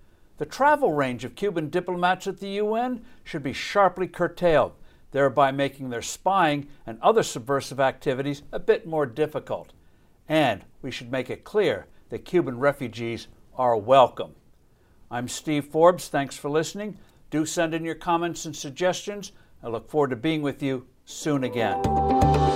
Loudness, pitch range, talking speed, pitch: -25 LUFS, 130-180 Hz, 155 wpm, 145 Hz